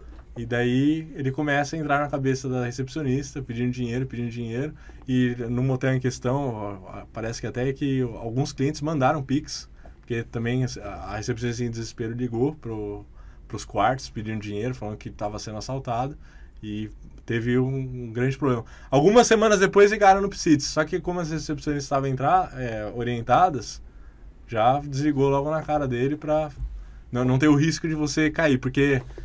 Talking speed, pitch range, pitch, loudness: 165 wpm, 115-145 Hz, 130 Hz, -24 LUFS